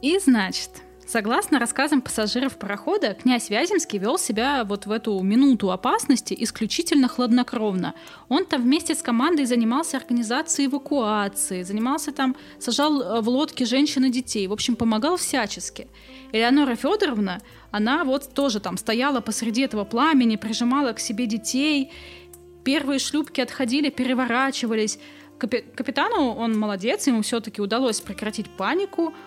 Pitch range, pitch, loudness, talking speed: 220-285 Hz, 250 Hz, -23 LUFS, 130 wpm